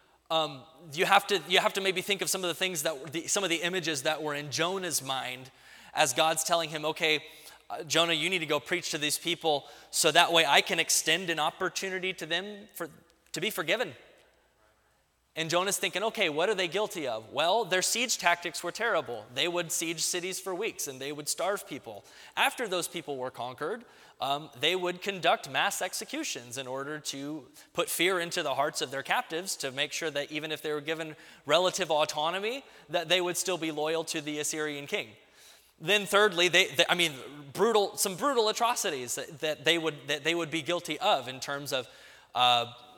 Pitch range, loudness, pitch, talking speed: 150-185 Hz, -29 LUFS, 165 Hz, 205 wpm